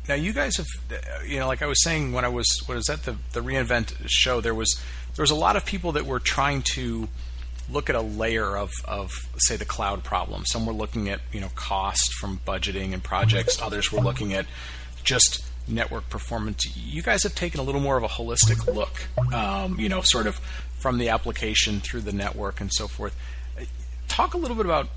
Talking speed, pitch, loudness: 215 wpm, 105 Hz, -24 LUFS